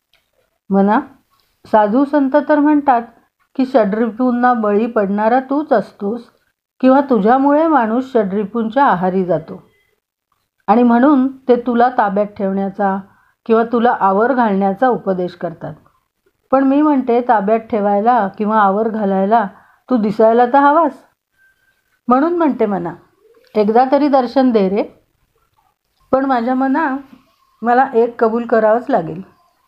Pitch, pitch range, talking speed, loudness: 240 Hz, 210-270 Hz, 115 wpm, -14 LUFS